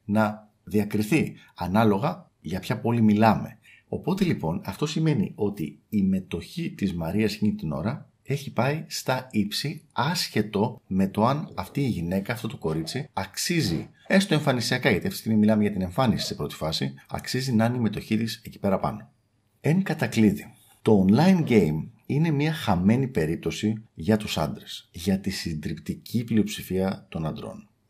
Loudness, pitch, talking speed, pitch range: -26 LUFS, 110 Hz, 160 wpm, 100-145 Hz